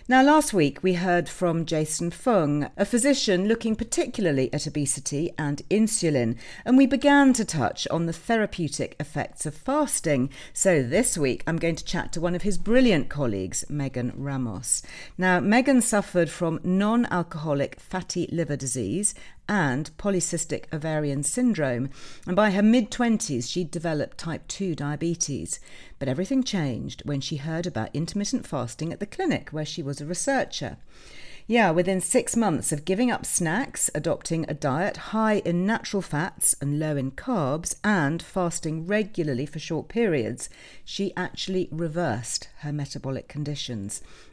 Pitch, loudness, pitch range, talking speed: 170 Hz, -25 LUFS, 145-205 Hz, 155 wpm